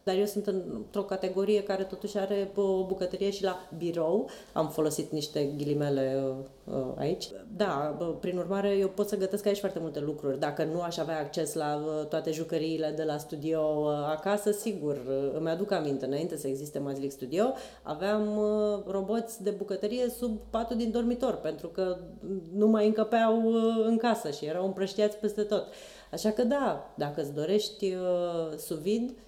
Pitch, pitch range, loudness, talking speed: 190 Hz, 155-210 Hz, -31 LUFS, 160 wpm